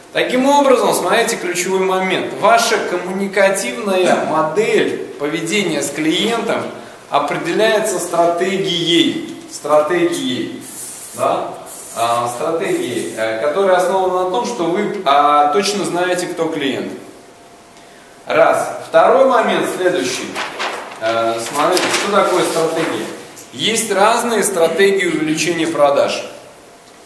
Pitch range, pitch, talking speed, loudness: 160-220 Hz, 185 Hz, 85 wpm, -16 LUFS